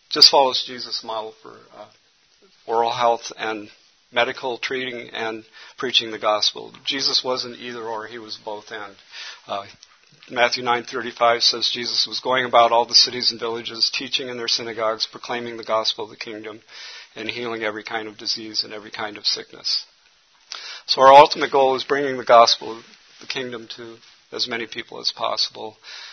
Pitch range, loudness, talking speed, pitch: 110-120 Hz, -20 LUFS, 170 wpm, 115 Hz